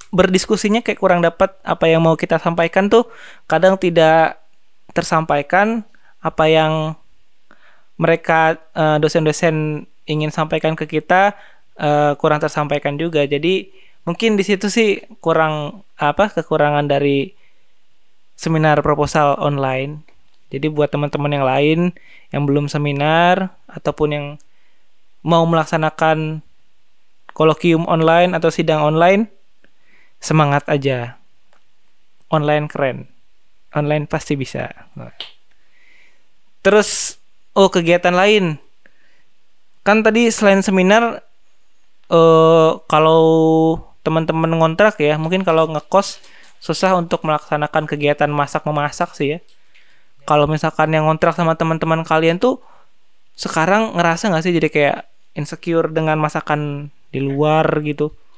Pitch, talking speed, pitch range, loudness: 160 Hz, 105 wpm, 150-180 Hz, -16 LUFS